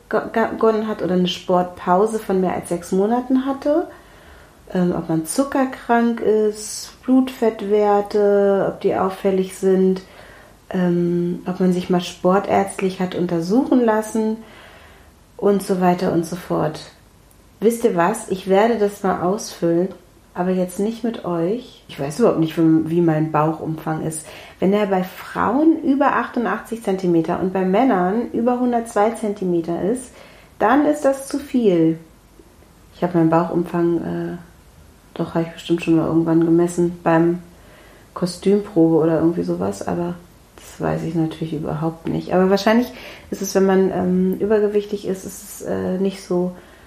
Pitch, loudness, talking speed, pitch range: 185 Hz, -19 LUFS, 145 wpm, 165-210 Hz